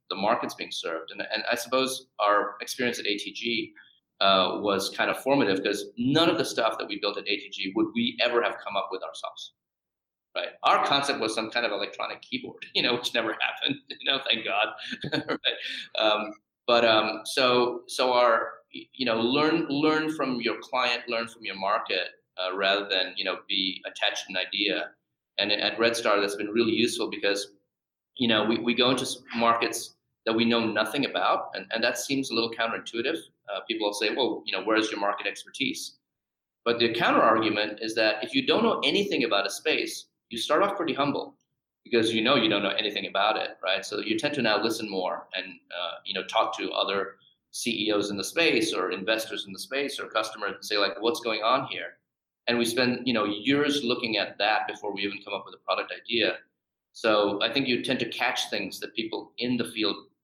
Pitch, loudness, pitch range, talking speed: 115 Hz, -26 LUFS, 105-125 Hz, 210 wpm